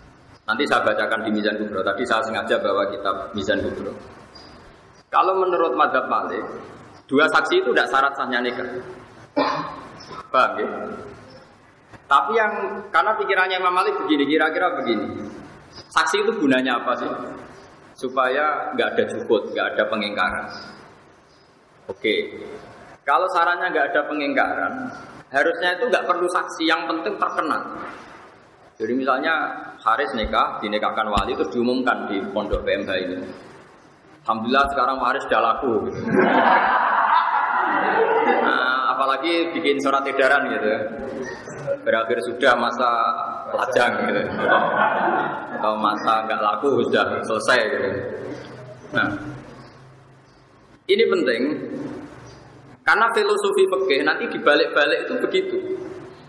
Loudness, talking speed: -21 LUFS, 115 wpm